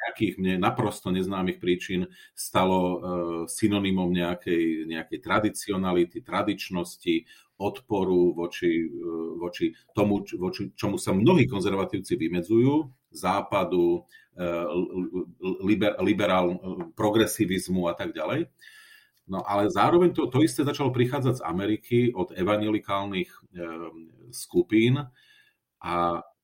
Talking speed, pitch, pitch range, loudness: 95 wpm, 95 Hz, 90-115 Hz, -26 LUFS